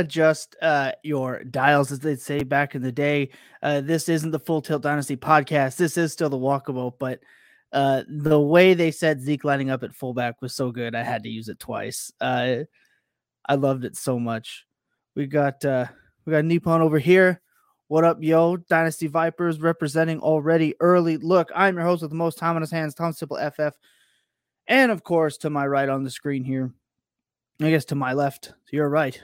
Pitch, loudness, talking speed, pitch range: 150 Hz, -23 LUFS, 195 wpm, 140-165 Hz